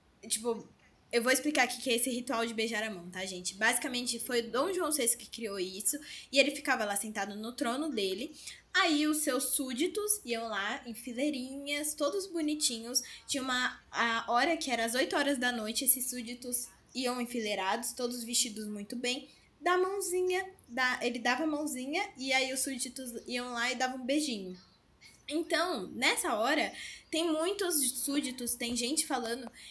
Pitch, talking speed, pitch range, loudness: 255 Hz, 175 wpm, 235-290 Hz, -31 LUFS